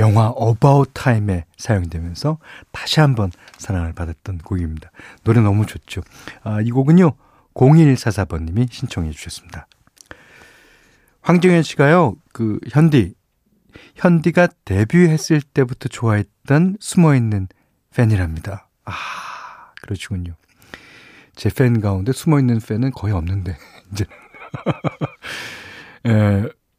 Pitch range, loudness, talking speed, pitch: 95-140 Hz, -17 LUFS, 235 characters per minute, 110 Hz